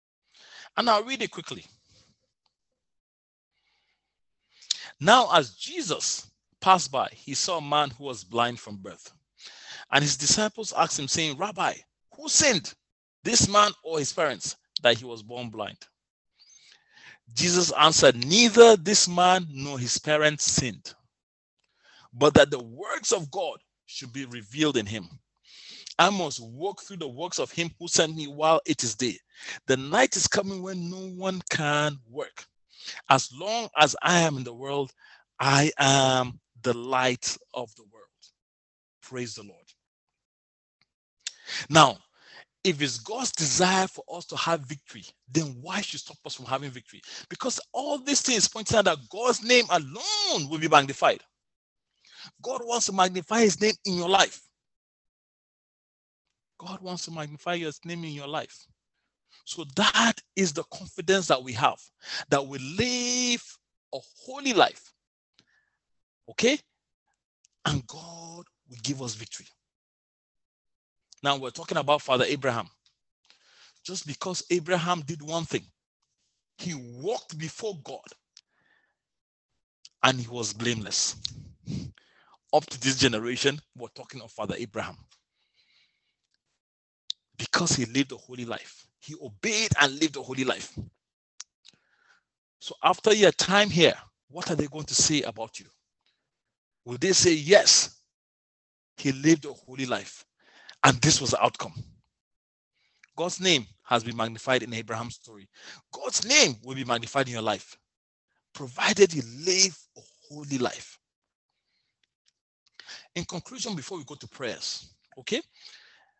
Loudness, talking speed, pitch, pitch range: -24 LUFS, 140 wpm, 150 Hz, 130-185 Hz